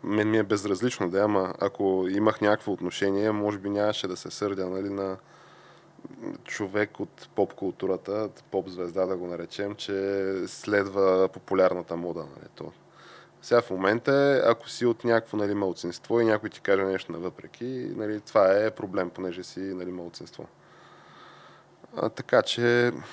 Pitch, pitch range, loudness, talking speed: 100 Hz, 95-105 Hz, -27 LUFS, 150 wpm